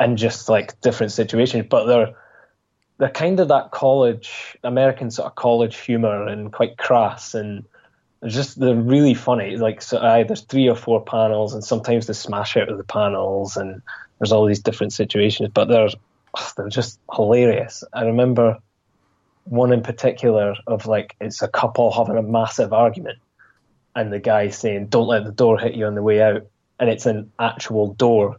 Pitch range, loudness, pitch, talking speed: 105-120 Hz, -19 LUFS, 110 Hz, 180 wpm